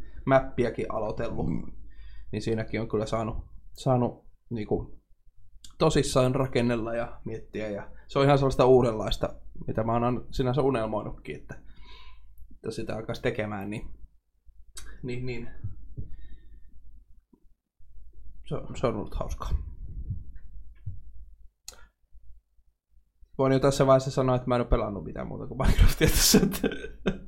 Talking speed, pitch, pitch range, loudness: 120 wpm, 110 Hz, 80-125 Hz, -27 LUFS